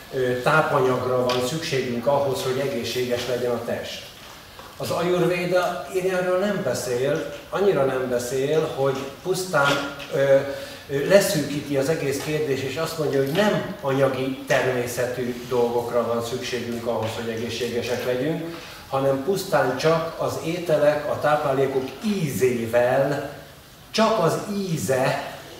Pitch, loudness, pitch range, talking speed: 135 Hz, -23 LUFS, 125-160 Hz, 115 wpm